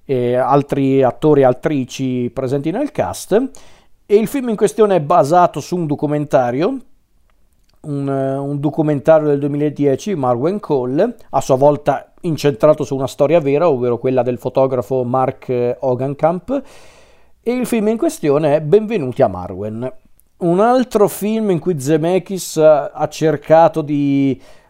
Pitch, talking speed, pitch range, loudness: 150 Hz, 140 wpm, 135-185 Hz, -16 LUFS